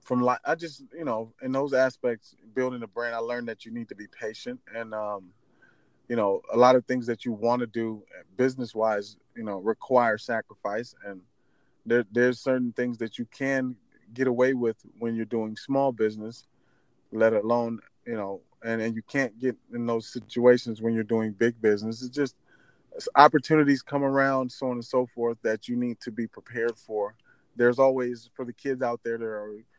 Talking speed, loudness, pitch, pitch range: 195 wpm, -27 LUFS, 120 Hz, 115-130 Hz